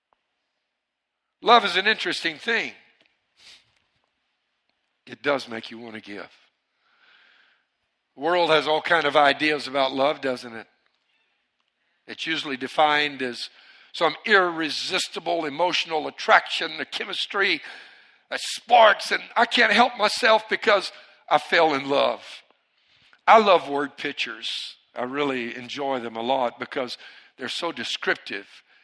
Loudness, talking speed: -22 LUFS, 125 wpm